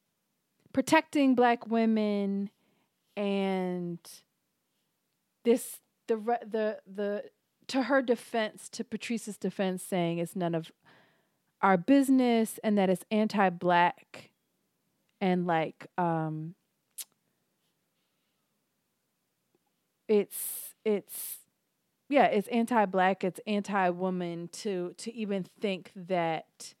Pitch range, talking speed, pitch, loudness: 180-225 Hz, 90 wpm, 200 Hz, -30 LUFS